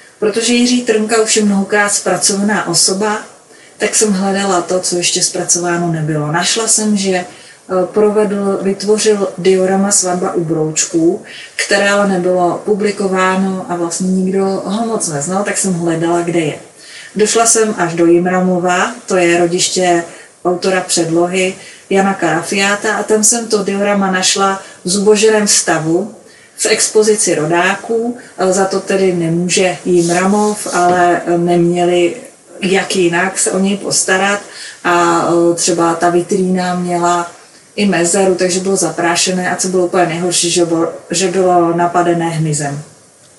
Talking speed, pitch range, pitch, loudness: 135 wpm, 175-200 Hz, 185 Hz, -13 LUFS